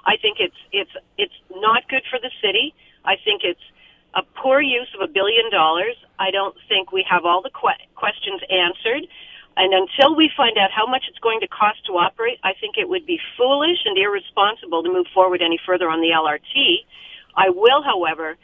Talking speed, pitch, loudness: 200 wpm, 245 Hz, -19 LUFS